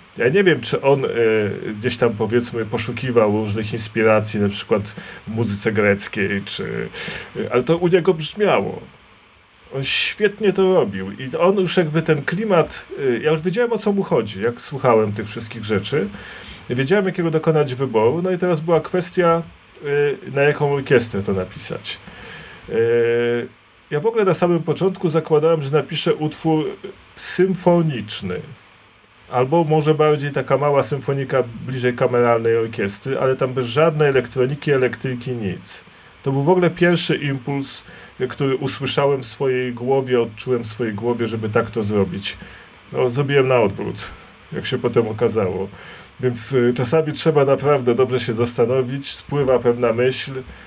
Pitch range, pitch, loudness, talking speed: 115-160 Hz, 130 Hz, -19 LUFS, 150 wpm